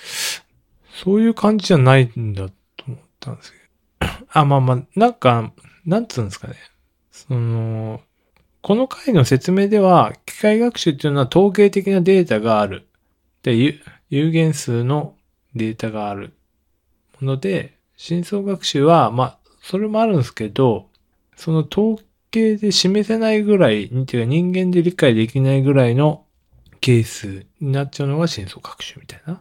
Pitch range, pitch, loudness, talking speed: 115-185 Hz, 140 Hz, -18 LUFS, 300 characters per minute